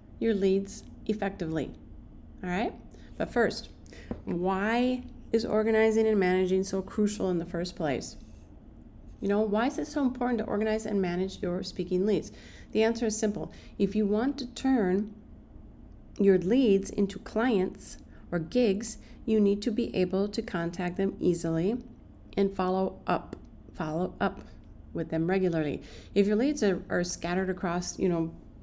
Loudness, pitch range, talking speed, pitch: -29 LUFS, 185-220 Hz, 155 wpm, 200 Hz